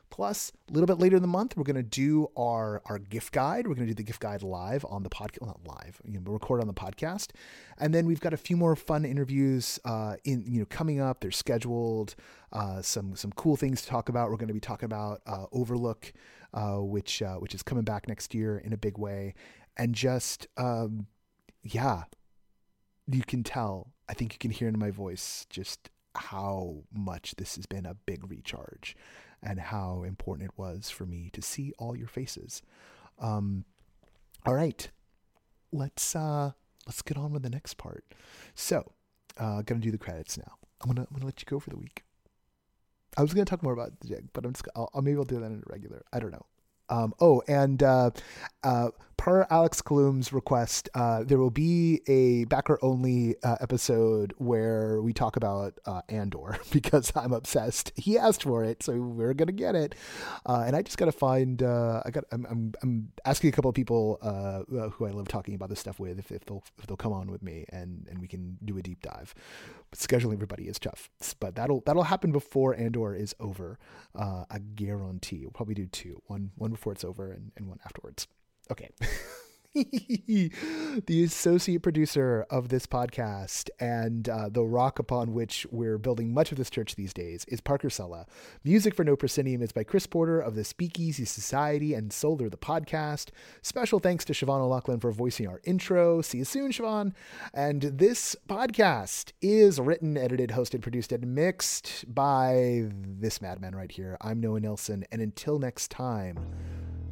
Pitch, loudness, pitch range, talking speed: 120 Hz, -30 LUFS, 105-140 Hz, 200 wpm